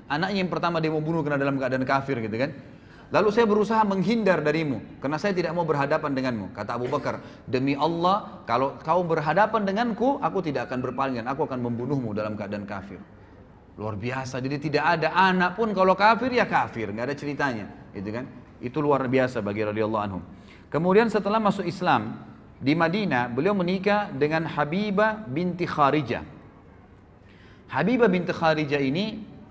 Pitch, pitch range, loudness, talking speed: 145 Hz, 120-185 Hz, -25 LUFS, 160 wpm